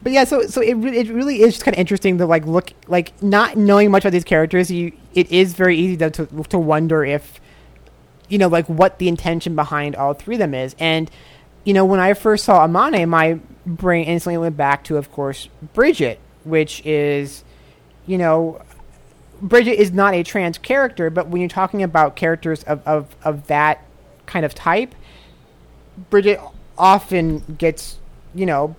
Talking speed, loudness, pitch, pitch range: 190 wpm, -17 LUFS, 170 Hz, 155-190 Hz